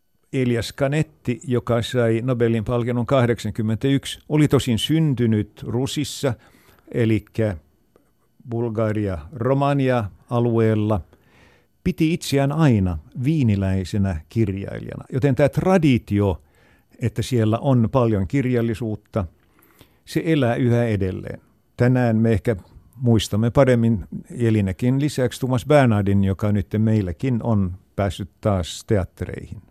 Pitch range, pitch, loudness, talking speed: 105-130 Hz, 115 Hz, -21 LUFS, 95 wpm